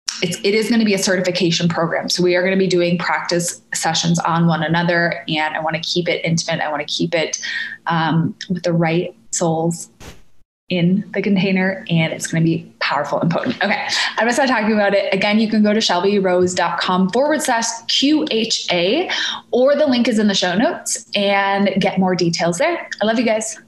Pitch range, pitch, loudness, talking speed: 170-215 Hz, 185 Hz, -17 LUFS, 210 wpm